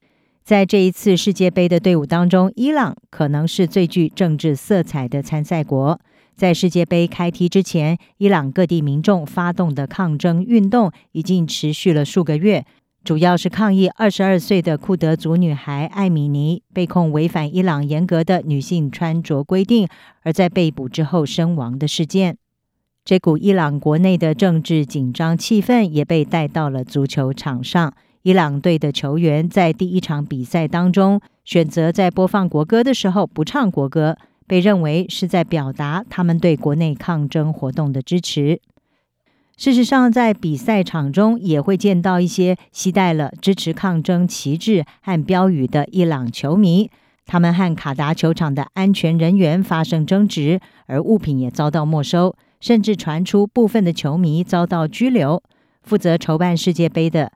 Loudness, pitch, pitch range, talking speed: -17 LUFS, 170 Hz, 155-190 Hz, 255 characters per minute